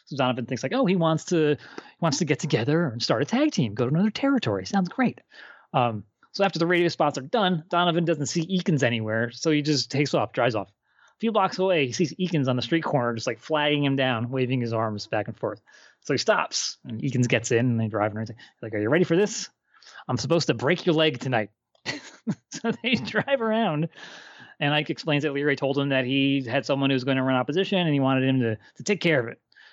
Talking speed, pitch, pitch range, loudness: 245 wpm, 150 Hz, 130-175 Hz, -25 LUFS